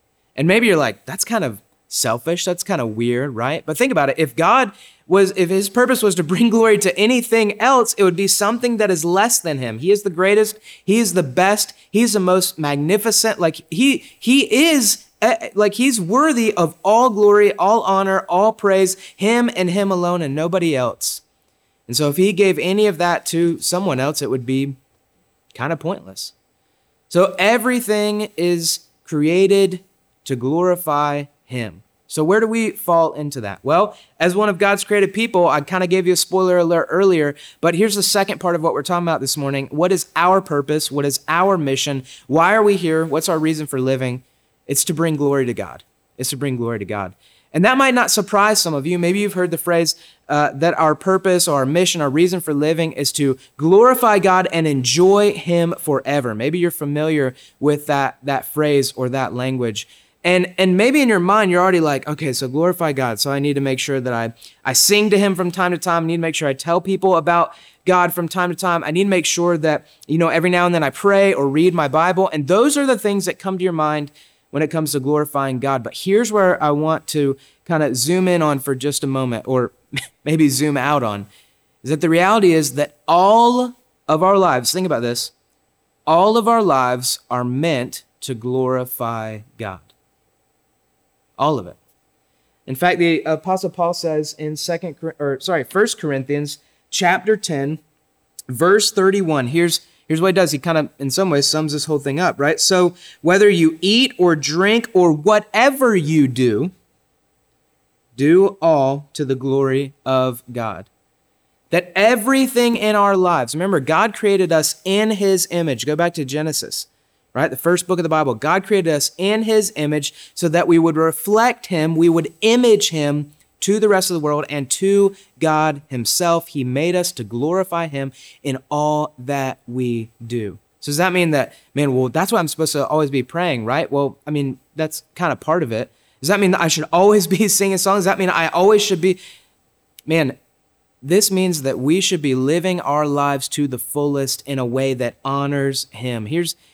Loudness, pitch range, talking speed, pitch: -17 LUFS, 140-190 Hz, 205 wpm, 165 Hz